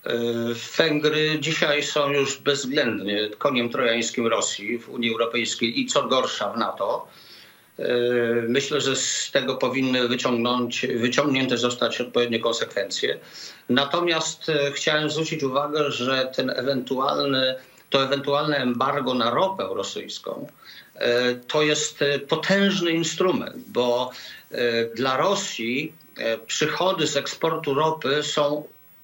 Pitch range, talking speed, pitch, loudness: 120-150 Hz, 105 wpm, 135 Hz, -23 LUFS